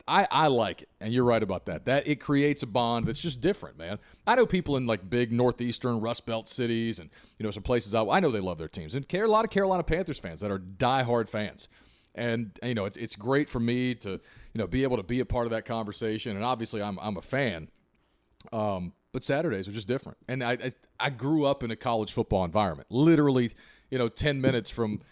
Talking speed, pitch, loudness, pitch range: 245 wpm, 120 Hz, -28 LUFS, 110-130 Hz